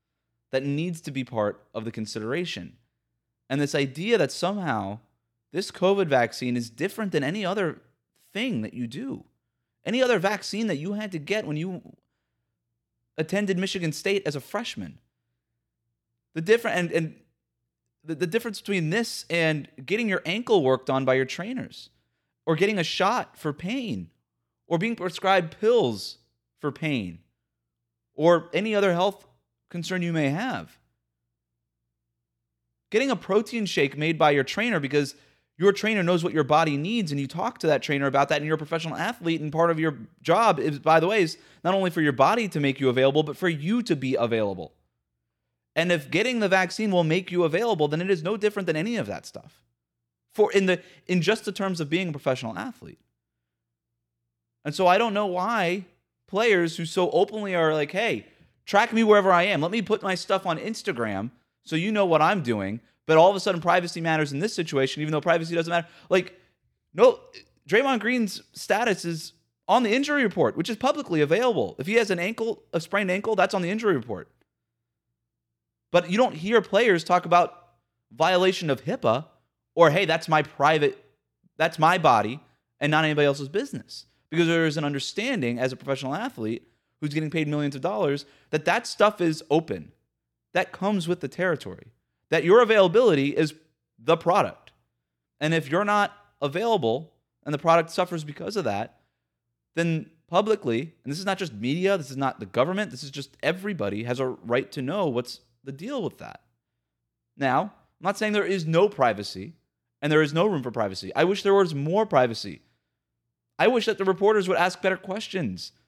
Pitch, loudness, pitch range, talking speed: 160 Hz, -24 LUFS, 130-195 Hz, 185 wpm